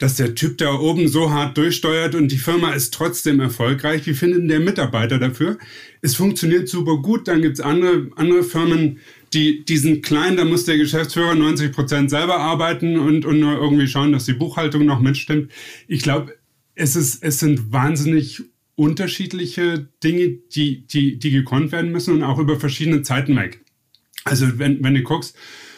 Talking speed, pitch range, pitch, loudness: 175 wpm, 145-165 Hz, 155 Hz, -18 LUFS